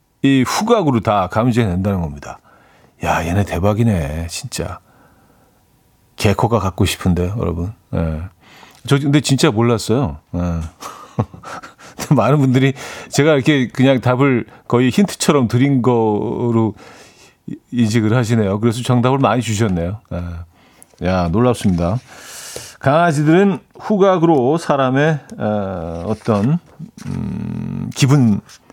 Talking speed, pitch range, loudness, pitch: 235 characters per minute, 95-135 Hz, -16 LUFS, 115 Hz